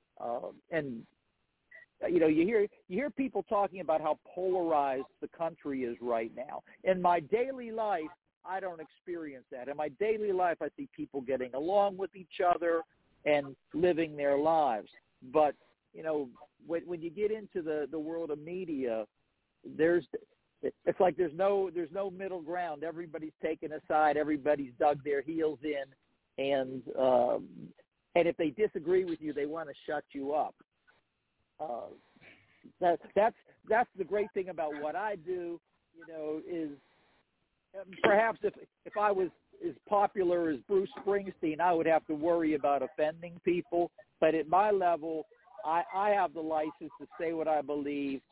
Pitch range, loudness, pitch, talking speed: 150-190 Hz, -32 LUFS, 170 Hz, 165 wpm